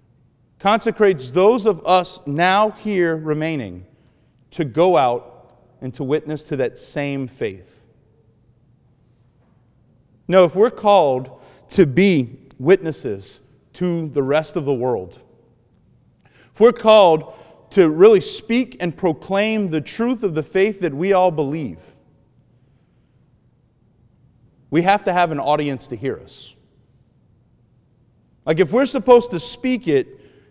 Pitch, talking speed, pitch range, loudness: 150 Hz, 125 wpm, 125-190 Hz, -18 LUFS